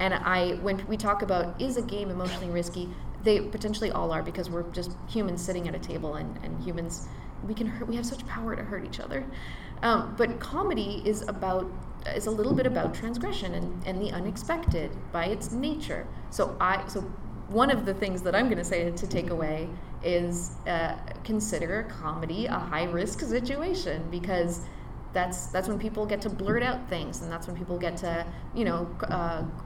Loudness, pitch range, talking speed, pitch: -30 LUFS, 175-215 Hz, 195 wpm, 185 Hz